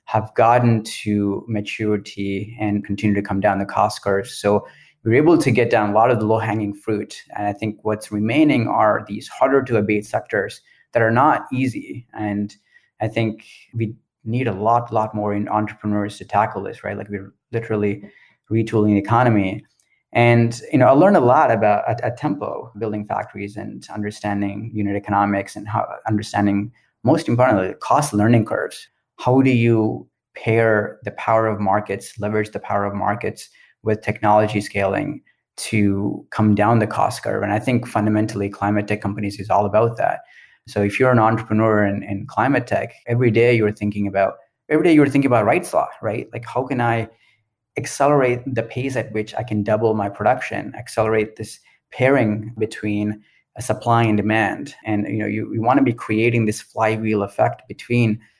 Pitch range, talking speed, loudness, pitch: 105-115 Hz, 180 wpm, -19 LUFS, 110 Hz